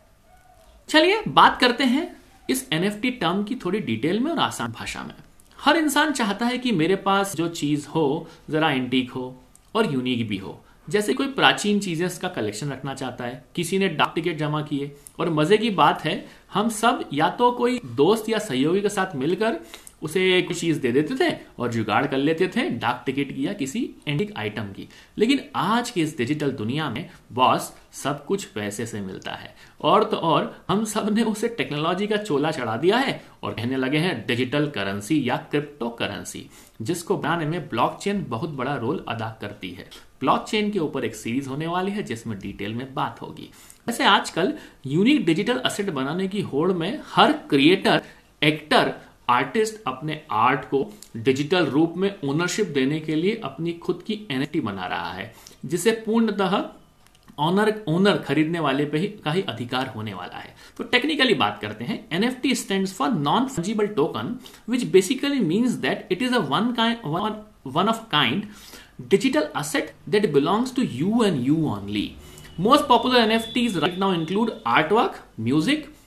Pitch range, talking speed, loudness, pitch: 135-215 Hz, 170 wpm, -23 LUFS, 175 Hz